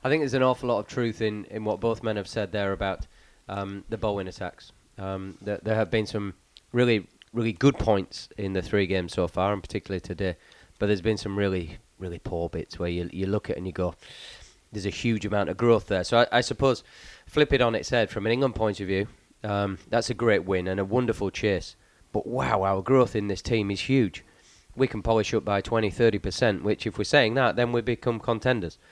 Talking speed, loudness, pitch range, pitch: 235 wpm, -26 LUFS, 95-115 Hz, 105 Hz